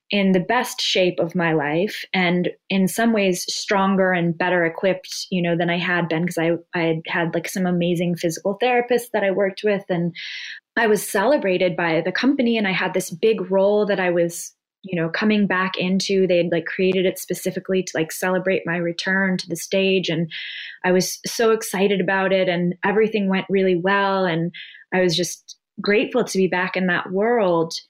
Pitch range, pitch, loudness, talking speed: 175-195 Hz, 185 Hz, -20 LUFS, 200 wpm